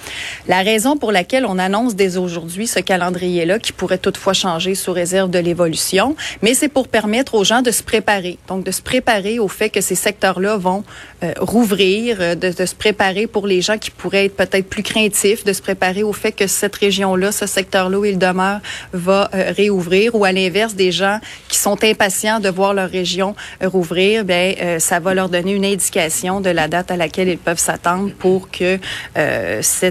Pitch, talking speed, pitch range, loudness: 195 Hz, 205 wpm, 185-210 Hz, -16 LUFS